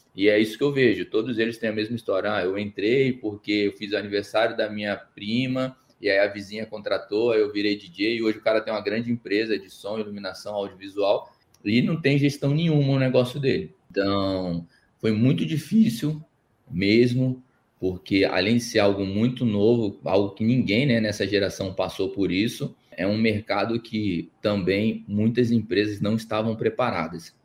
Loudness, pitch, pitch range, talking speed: -24 LUFS, 110 Hz, 100-125 Hz, 180 wpm